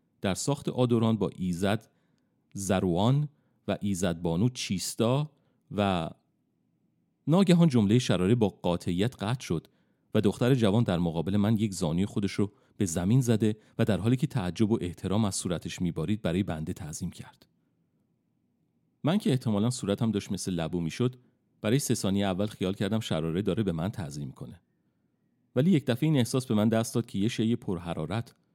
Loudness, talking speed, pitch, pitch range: -28 LUFS, 165 wpm, 110 Hz, 95-125 Hz